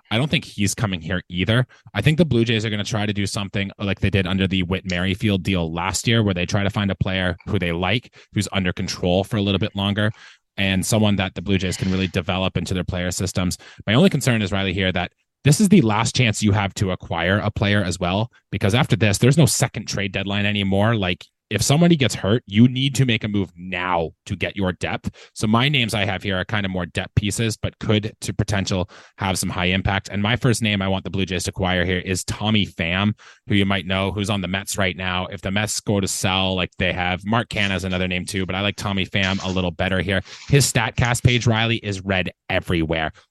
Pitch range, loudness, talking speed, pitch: 95-110 Hz, -21 LUFS, 250 wpm, 100 Hz